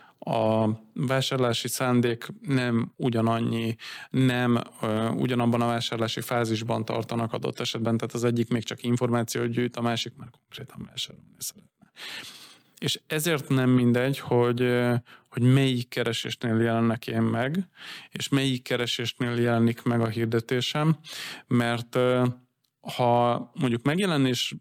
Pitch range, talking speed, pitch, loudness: 115-130 Hz, 115 wpm, 120 Hz, -26 LUFS